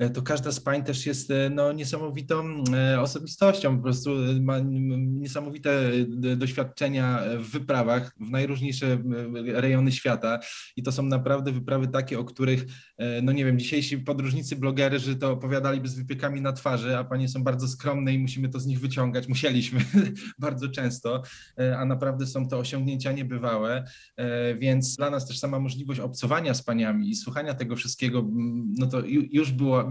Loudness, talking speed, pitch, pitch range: -27 LUFS, 155 wpm, 130 Hz, 125-140 Hz